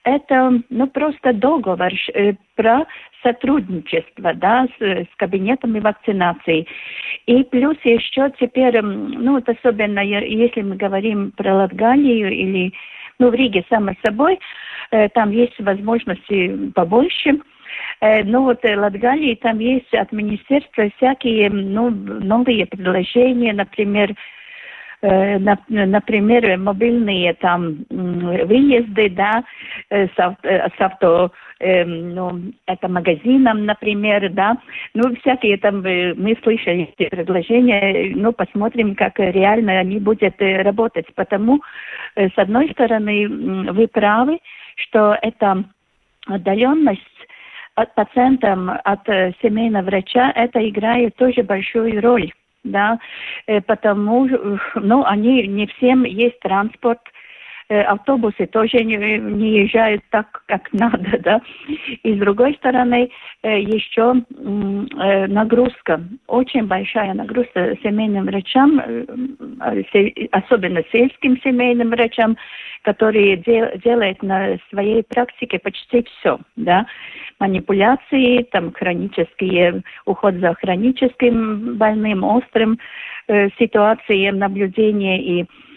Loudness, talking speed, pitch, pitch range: -17 LUFS, 105 wpm, 220 Hz, 195-245 Hz